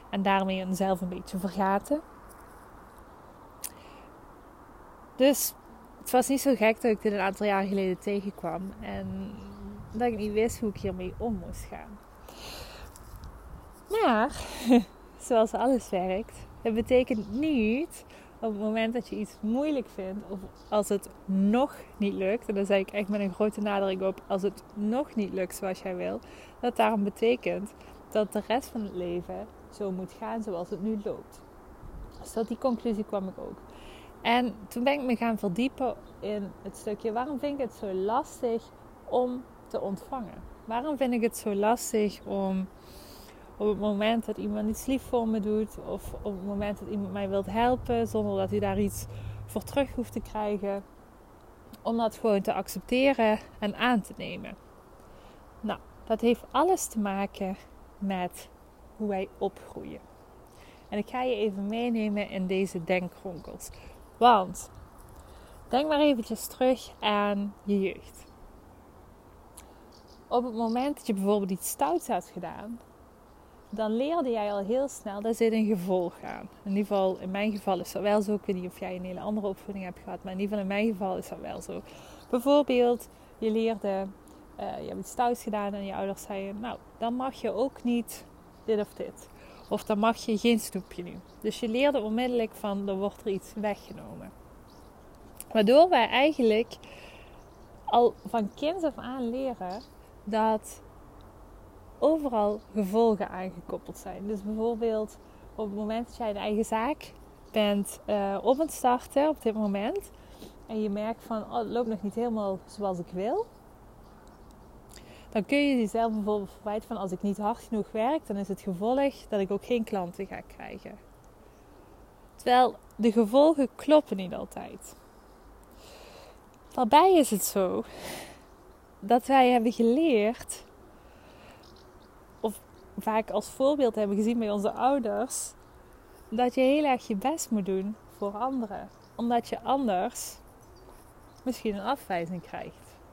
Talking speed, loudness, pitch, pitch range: 160 wpm, -29 LUFS, 215 Hz, 195-240 Hz